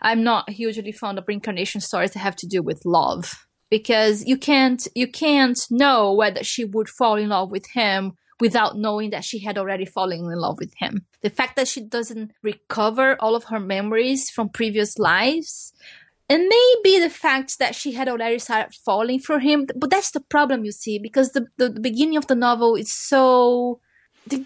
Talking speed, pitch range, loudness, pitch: 195 wpm, 210-265 Hz, -20 LUFS, 230 Hz